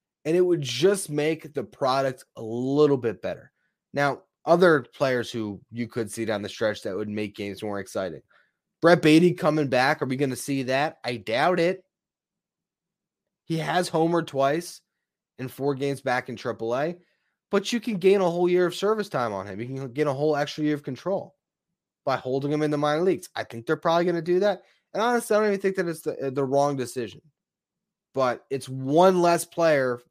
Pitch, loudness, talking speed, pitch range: 150 Hz, -25 LUFS, 205 wpm, 130-180 Hz